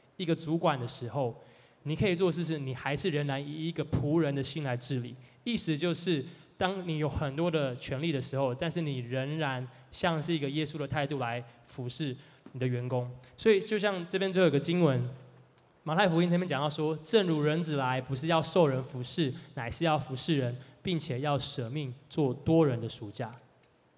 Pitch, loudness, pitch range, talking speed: 145 Hz, -31 LUFS, 130-165 Hz, 285 characters per minute